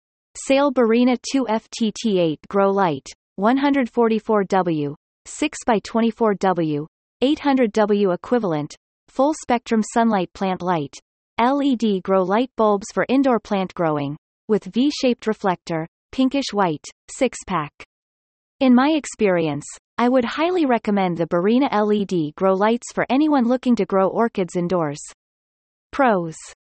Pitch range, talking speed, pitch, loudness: 180-250 Hz, 115 wpm, 215 Hz, -20 LUFS